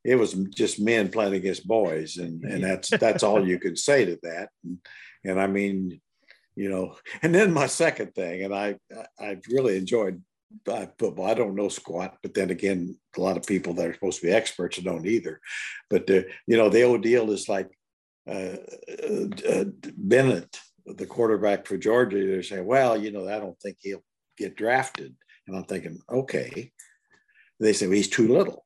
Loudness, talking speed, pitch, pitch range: -25 LUFS, 195 wpm, 100 Hz, 95-120 Hz